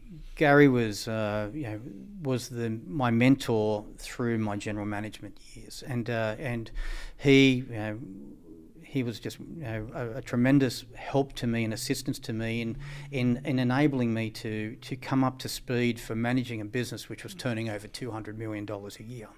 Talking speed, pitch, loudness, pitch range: 180 wpm, 120 Hz, -29 LUFS, 110-130 Hz